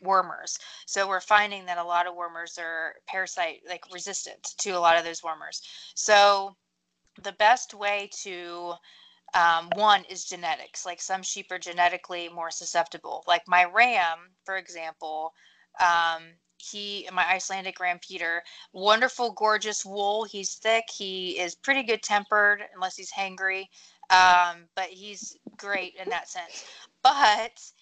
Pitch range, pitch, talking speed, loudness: 175-205 Hz, 185 Hz, 145 wpm, -25 LUFS